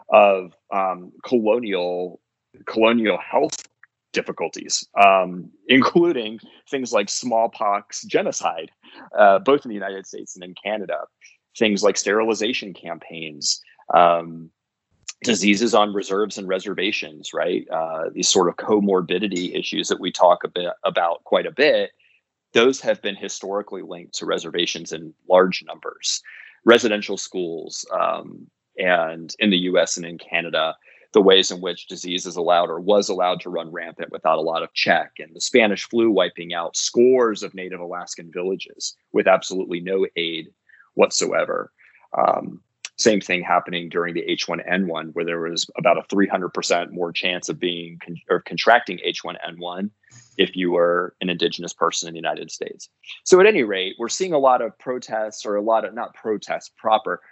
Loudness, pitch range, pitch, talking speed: -21 LUFS, 90-110 Hz, 95 Hz, 160 wpm